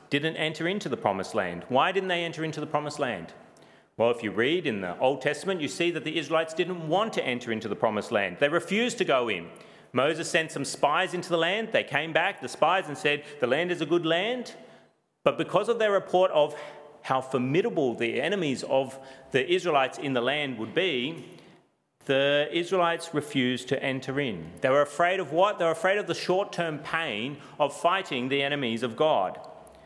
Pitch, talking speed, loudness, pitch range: 155 Hz, 205 wpm, -27 LUFS, 140-175 Hz